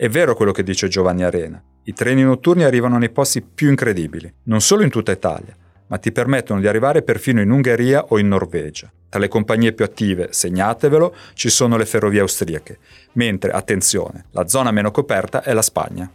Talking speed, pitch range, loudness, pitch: 190 wpm, 90-125 Hz, -17 LUFS, 110 Hz